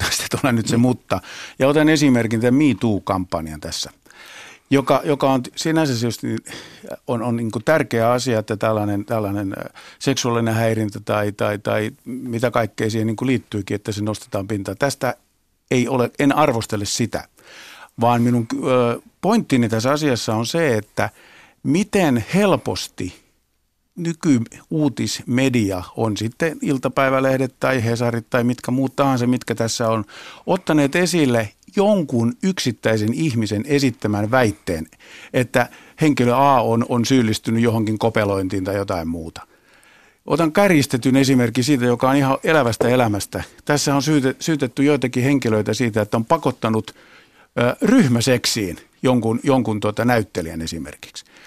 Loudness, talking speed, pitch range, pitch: -19 LUFS, 125 wpm, 110-135 Hz, 120 Hz